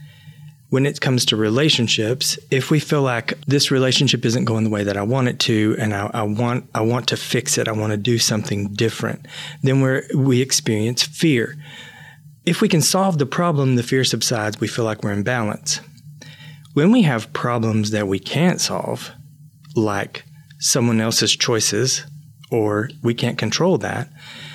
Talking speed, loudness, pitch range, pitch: 175 wpm, -19 LUFS, 110-150 Hz, 130 Hz